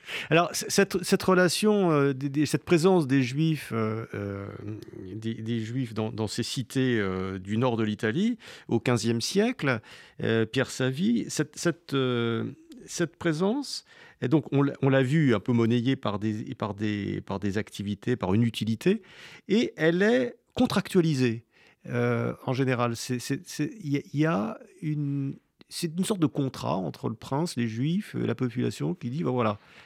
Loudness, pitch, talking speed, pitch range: -27 LUFS, 135 Hz, 160 wpm, 115-165 Hz